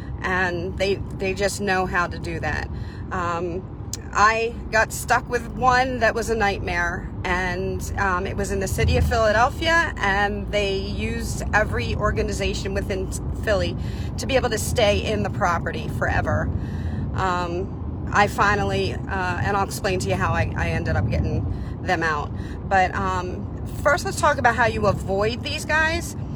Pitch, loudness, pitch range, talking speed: 205 Hz, -23 LUFS, 195-250 Hz, 165 wpm